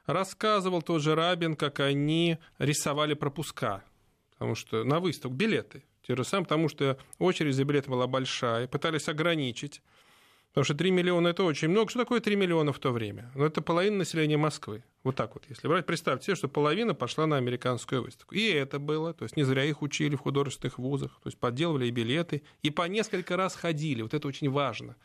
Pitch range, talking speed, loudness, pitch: 135-170 Hz, 200 wpm, -29 LUFS, 150 Hz